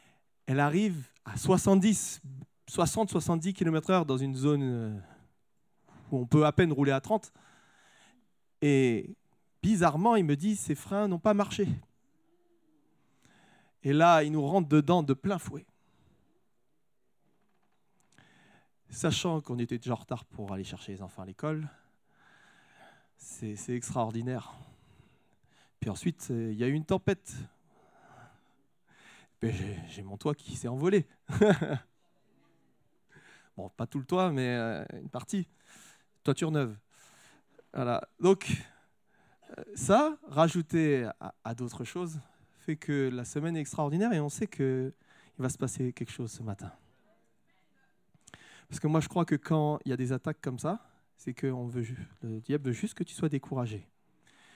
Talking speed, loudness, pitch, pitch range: 135 wpm, -30 LUFS, 145 Hz, 125-175 Hz